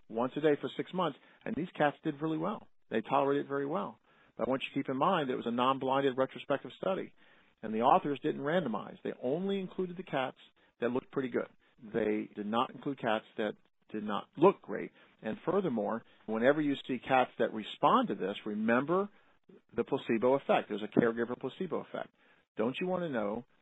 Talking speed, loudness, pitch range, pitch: 200 wpm, -33 LUFS, 115-160 Hz, 135 Hz